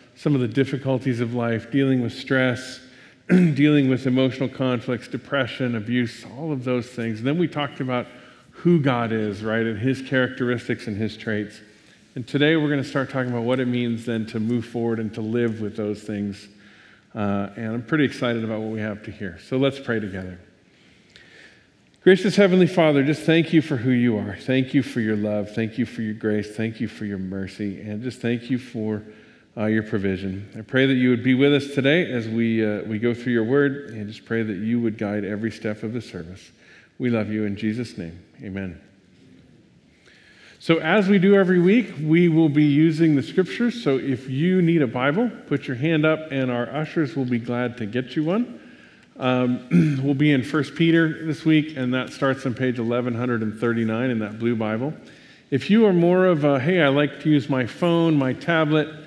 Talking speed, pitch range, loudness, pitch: 210 wpm, 110-145 Hz, -22 LUFS, 125 Hz